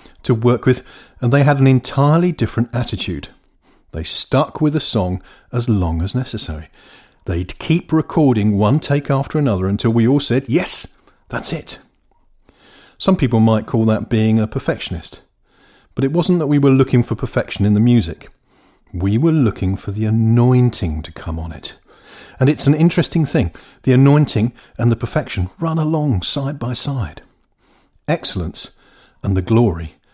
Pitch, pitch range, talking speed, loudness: 120 Hz, 105-140 Hz, 165 wpm, -17 LUFS